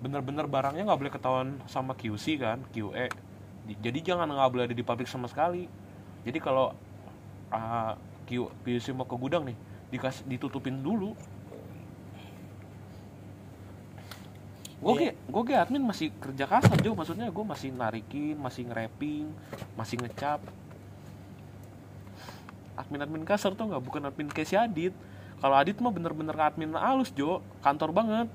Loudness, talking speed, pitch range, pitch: -31 LUFS, 130 wpm, 105-150 Hz, 125 Hz